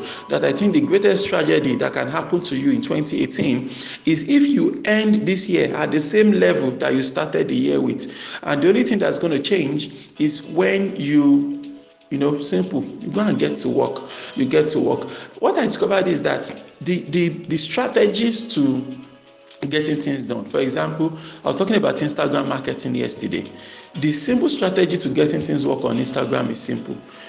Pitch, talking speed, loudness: 175 Hz, 185 wpm, -19 LUFS